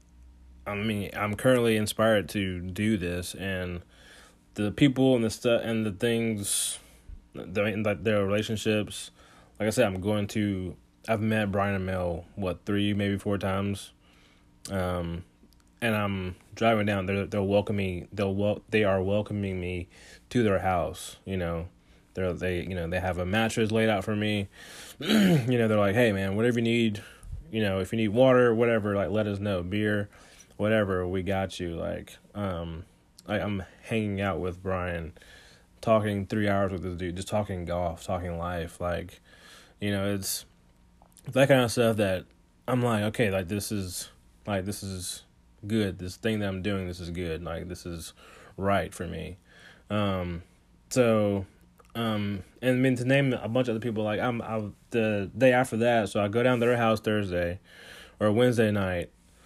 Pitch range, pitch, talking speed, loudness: 90-110 Hz, 100 Hz, 180 wpm, -28 LUFS